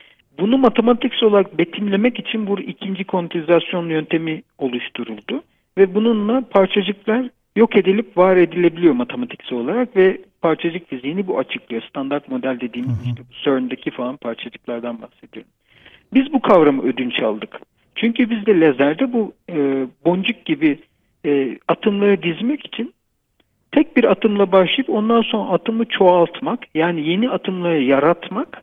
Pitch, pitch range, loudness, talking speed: 190 Hz, 150-230 Hz, -18 LUFS, 125 wpm